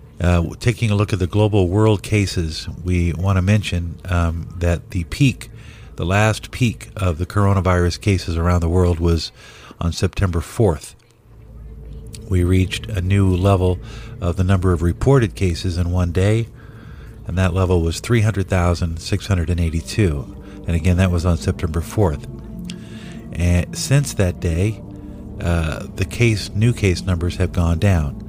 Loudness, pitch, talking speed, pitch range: -19 LUFS, 95 Hz, 165 wpm, 90-105 Hz